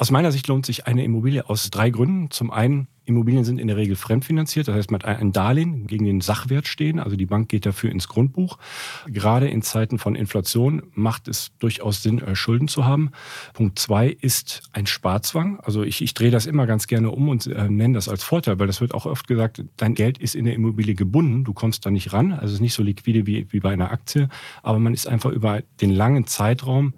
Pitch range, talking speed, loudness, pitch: 105-130 Hz, 230 wpm, -21 LUFS, 115 Hz